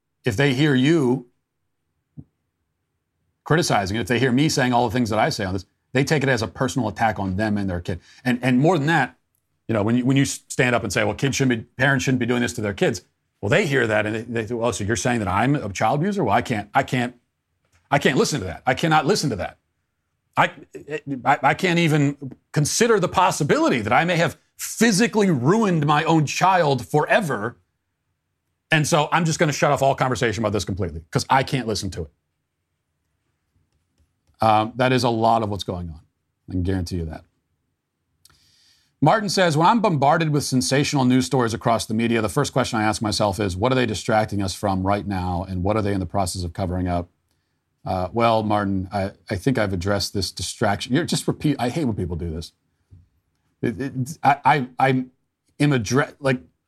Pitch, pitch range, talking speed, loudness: 120 Hz, 100-135 Hz, 215 wpm, -21 LUFS